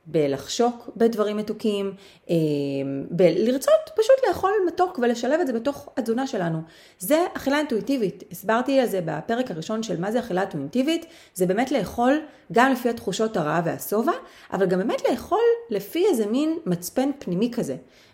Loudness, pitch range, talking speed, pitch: -24 LUFS, 185-275 Hz, 145 wpm, 230 Hz